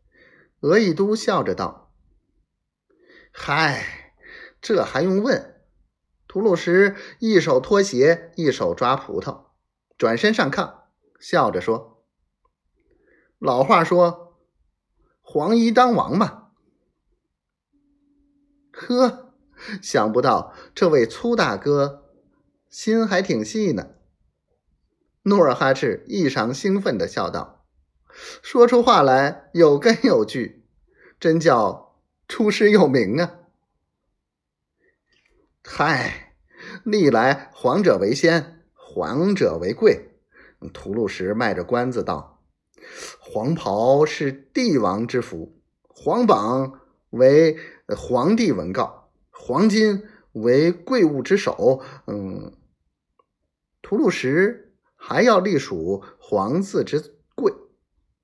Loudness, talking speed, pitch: -20 LUFS, 135 characters per minute, 180 Hz